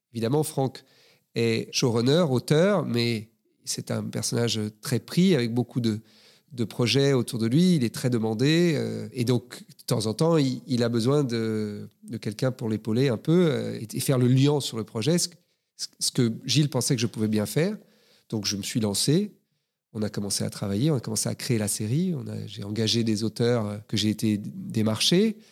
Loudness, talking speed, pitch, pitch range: -25 LUFS, 205 wpm, 120 Hz, 110-150 Hz